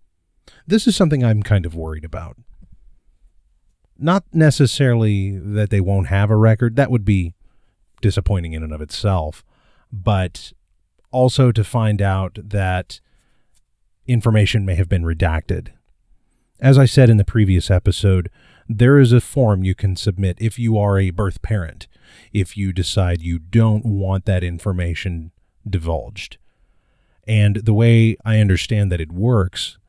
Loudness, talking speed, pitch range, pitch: -17 LUFS, 145 wpm, 90-110 Hz, 100 Hz